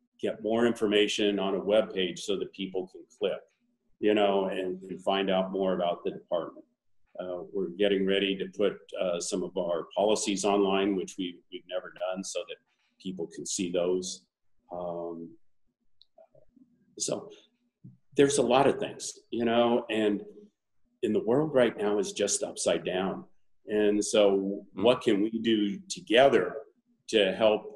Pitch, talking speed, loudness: 105 Hz, 160 wpm, -28 LUFS